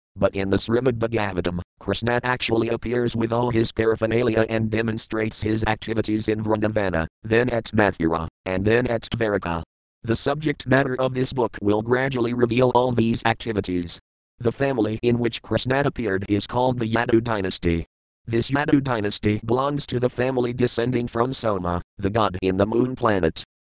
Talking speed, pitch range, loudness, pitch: 165 wpm, 105-120 Hz, -22 LUFS, 115 Hz